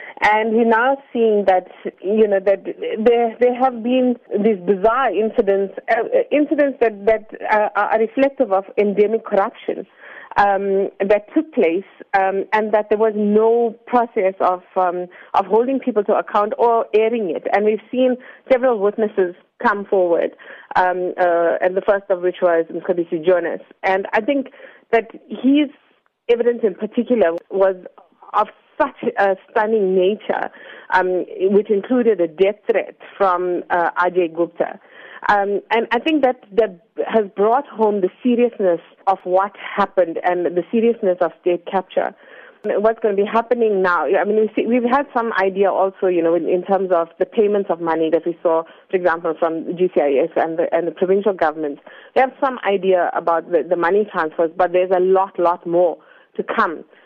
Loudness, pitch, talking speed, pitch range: -18 LUFS, 200 Hz, 170 wpm, 180-230 Hz